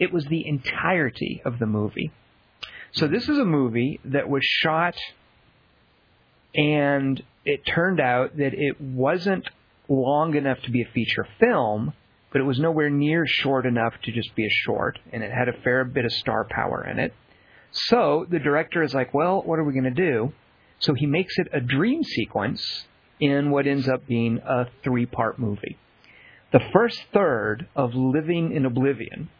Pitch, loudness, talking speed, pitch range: 140 Hz, -23 LUFS, 180 wpm, 125-160 Hz